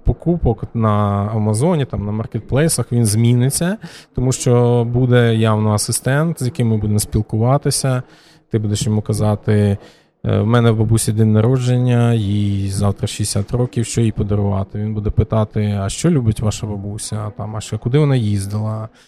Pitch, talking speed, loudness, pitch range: 110 Hz, 155 wpm, -17 LUFS, 105-125 Hz